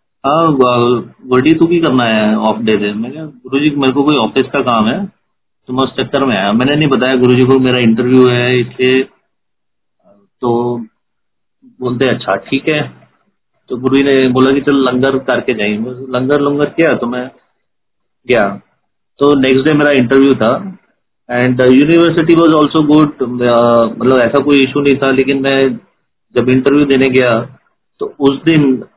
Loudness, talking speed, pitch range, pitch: -11 LUFS, 160 wpm, 125-145 Hz, 130 Hz